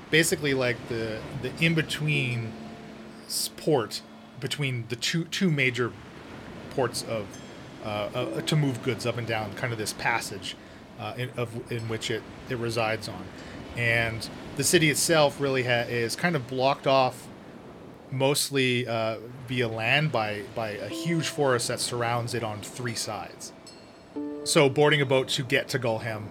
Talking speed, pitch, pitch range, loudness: 155 wpm, 125 Hz, 115-140 Hz, -27 LUFS